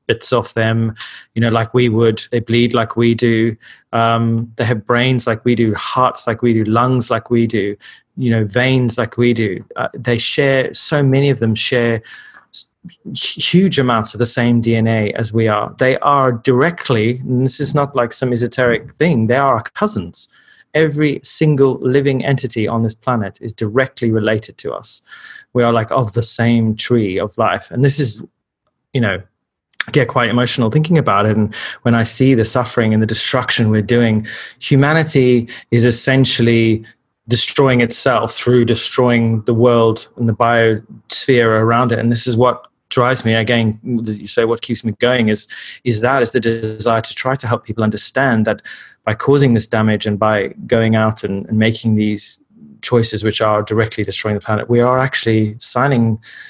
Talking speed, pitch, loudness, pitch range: 185 wpm, 115 Hz, -15 LUFS, 110-125 Hz